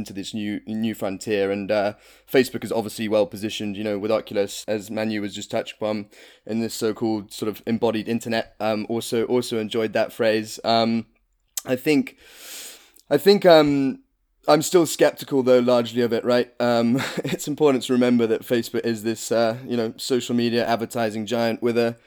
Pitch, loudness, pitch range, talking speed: 115 Hz, -22 LUFS, 110-125 Hz, 180 wpm